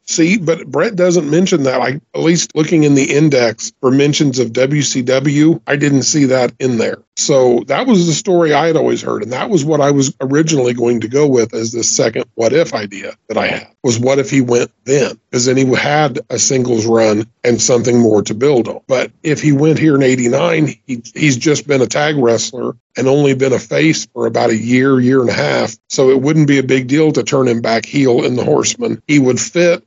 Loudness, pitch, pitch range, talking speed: -13 LUFS, 135 Hz, 120-150 Hz, 235 wpm